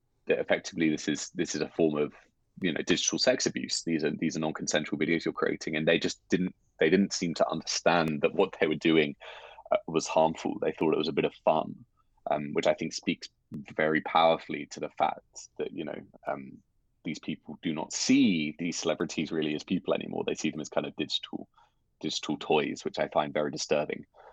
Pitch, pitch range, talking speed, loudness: 80 Hz, 80-90 Hz, 210 wpm, -29 LUFS